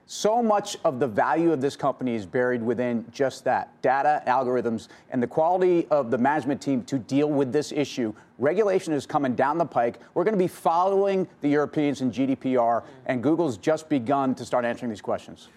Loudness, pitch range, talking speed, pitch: -25 LUFS, 125-160 Hz, 195 wpm, 140 Hz